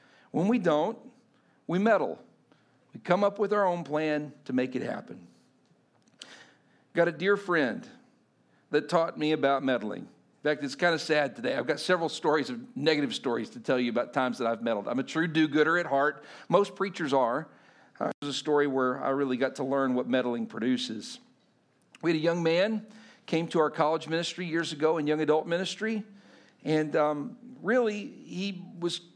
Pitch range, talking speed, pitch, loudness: 140-180 Hz, 185 wpm, 160 Hz, -29 LUFS